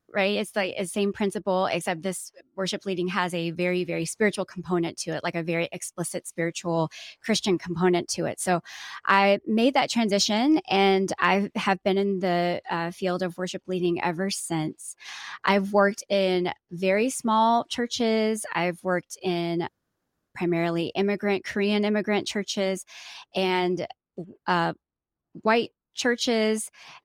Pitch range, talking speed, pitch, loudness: 175-205 Hz, 140 wpm, 190 Hz, -26 LUFS